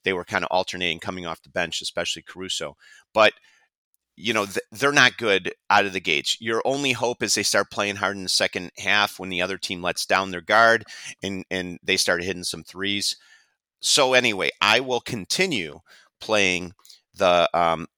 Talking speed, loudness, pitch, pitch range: 185 wpm, -22 LUFS, 95 Hz, 90-100 Hz